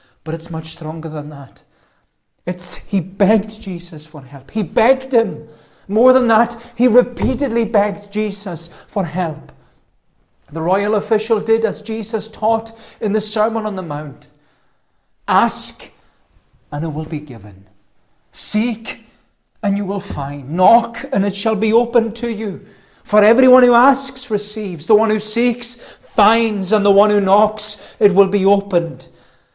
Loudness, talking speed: -16 LUFS, 150 wpm